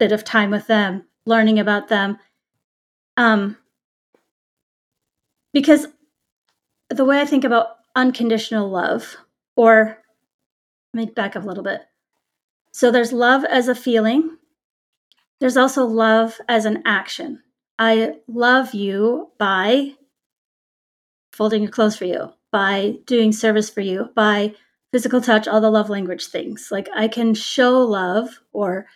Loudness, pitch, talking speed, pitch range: -18 LUFS, 225 Hz, 135 wpm, 210-250 Hz